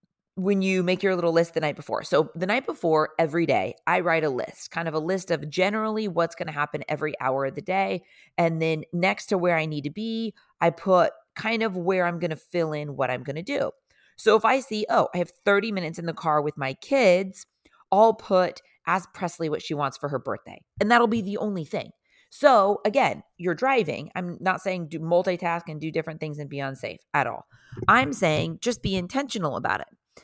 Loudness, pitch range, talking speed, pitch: -25 LUFS, 160-200 Hz, 220 wpm, 175 Hz